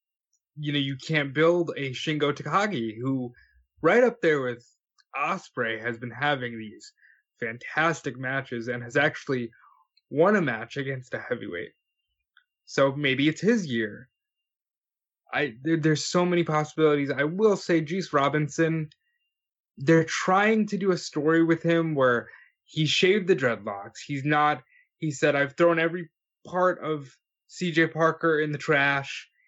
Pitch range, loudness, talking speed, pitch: 135-170 Hz, -25 LUFS, 145 wpm, 150 Hz